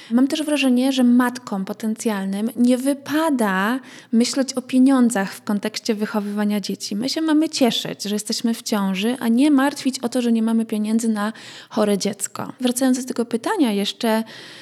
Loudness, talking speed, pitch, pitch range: -20 LUFS, 165 wpm, 235 Hz, 215-260 Hz